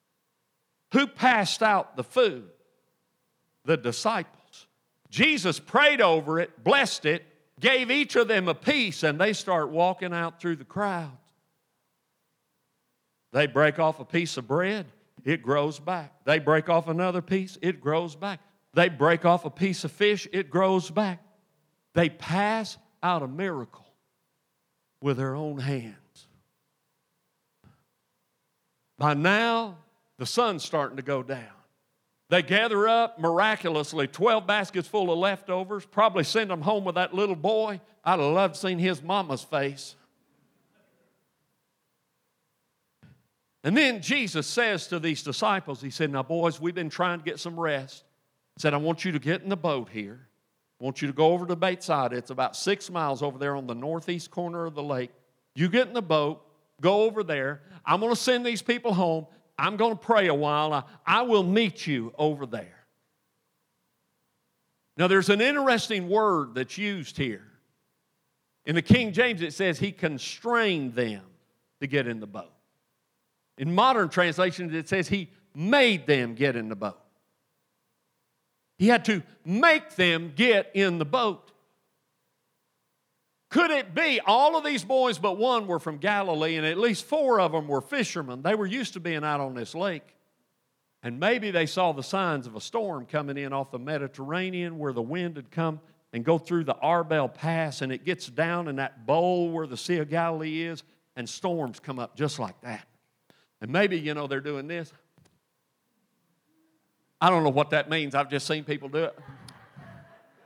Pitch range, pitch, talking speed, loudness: 150-200 Hz, 170 Hz, 165 wpm, -26 LUFS